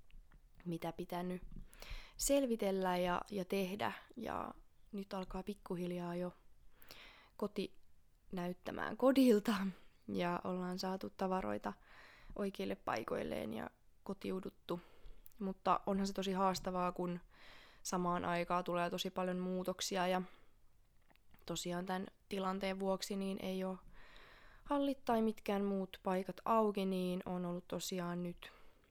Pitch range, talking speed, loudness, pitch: 175-195 Hz, 105 wpm, -40 LUFS, 185 Hz